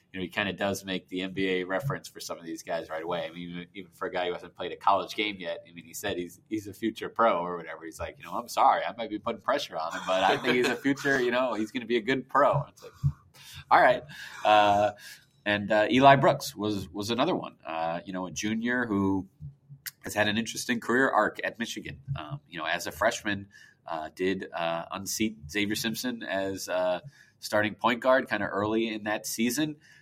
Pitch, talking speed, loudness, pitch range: 105 Hz, 235 wpm, -28 LUFS, 95-115 Hz